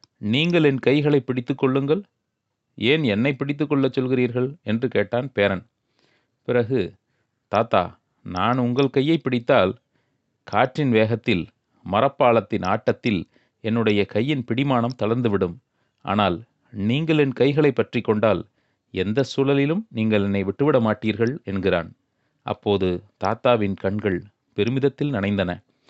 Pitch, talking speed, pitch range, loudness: 120 Hz, 105 wpm, 105-135 Hz, -22 LUFS